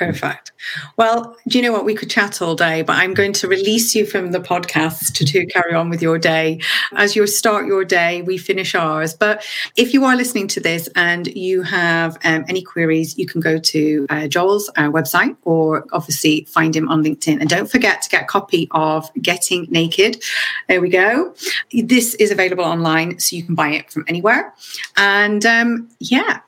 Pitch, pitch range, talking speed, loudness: 175 Hz, 160-205 Hz, 200 wpm, -16 LUFS